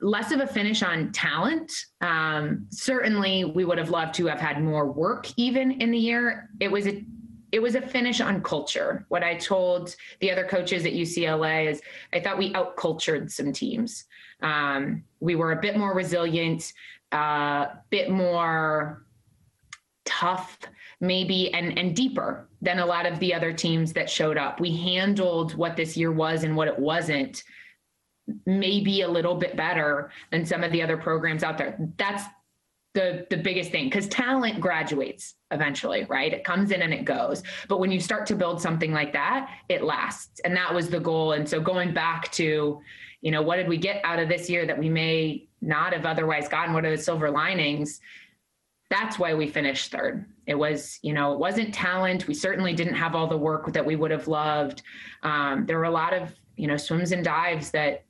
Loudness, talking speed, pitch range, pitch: -26 LUFS, 195 wpm, 160-190 Hz, 175 Hz